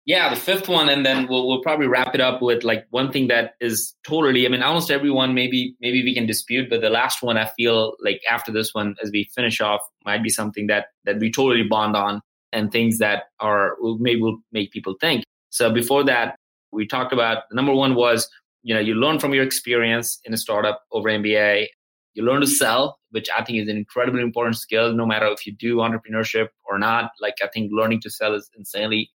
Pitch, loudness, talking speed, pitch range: 115 Hz, -20 LUFS, 220 wpm, 110-125 Hz